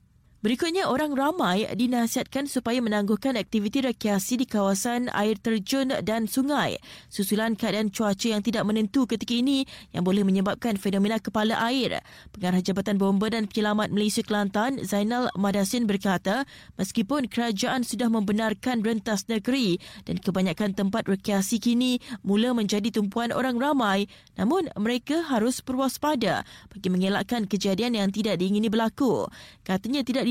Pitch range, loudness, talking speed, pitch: 205-245 Hz, -26 LUFS, 135 wpm, 225 Hz